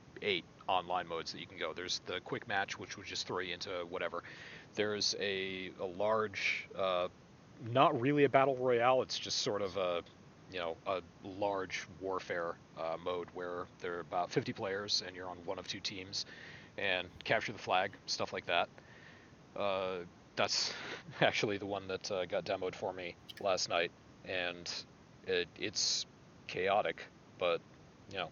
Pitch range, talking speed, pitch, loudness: 90-110 Hz, 165 wpm, 95 Hz, -36 LUFS